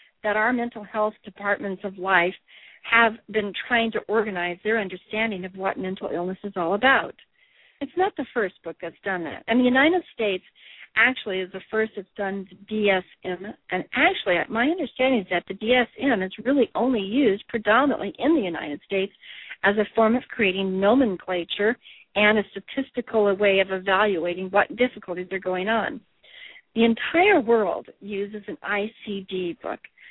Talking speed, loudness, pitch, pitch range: 165 wpm, -23 LUFS, 210 Hz, 190-245 Hz